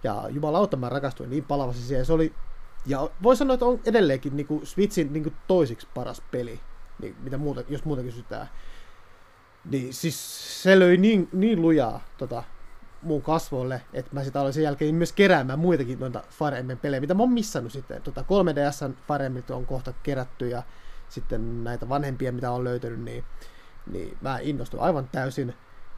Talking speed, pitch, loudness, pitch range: 170 wpm, 140 Hz, -26 LUFS, 125-160 Hz